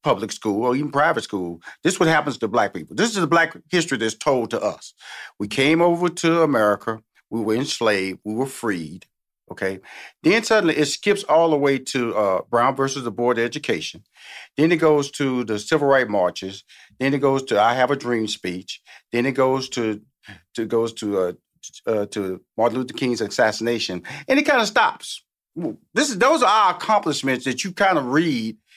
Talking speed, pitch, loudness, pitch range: 200 wpm, 130 Hz, -21 LUFS, 110-155 Hz